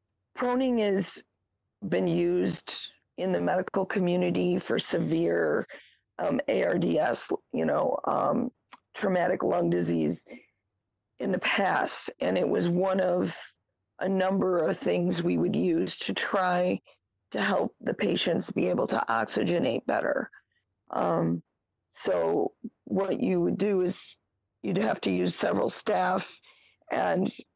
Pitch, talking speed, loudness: 180 Hz, 125 wpm, -28 LUFS